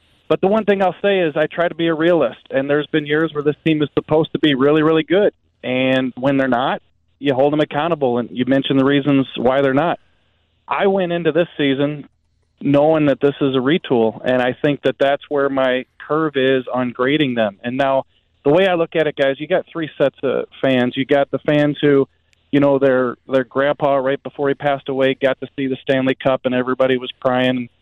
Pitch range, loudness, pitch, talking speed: 130-150 Hz, -17 LUFS, 140 Hz, 230 wpm